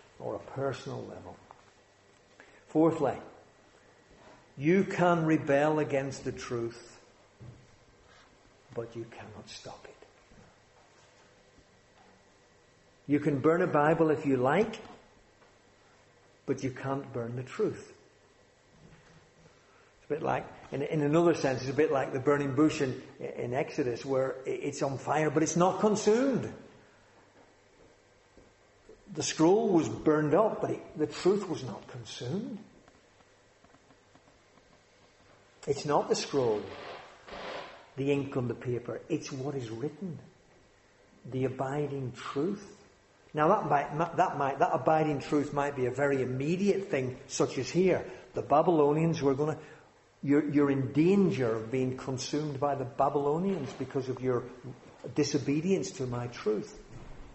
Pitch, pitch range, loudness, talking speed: 140 Hz, 120-155 Hz, -30 LUFS, 130 wpm